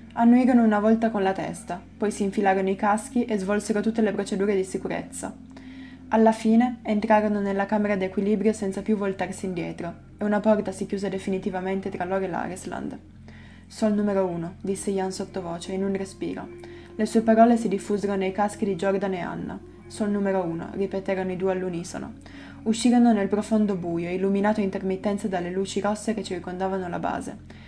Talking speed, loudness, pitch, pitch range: 170 wpm, -25 LUFS, 200 Hz, 190-215 Hz